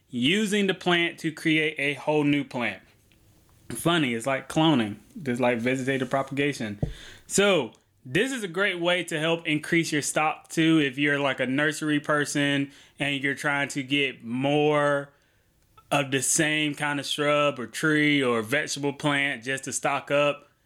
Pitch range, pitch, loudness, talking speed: 135-155 Hz, 145 Hz, -25 LUFS, 165 wpm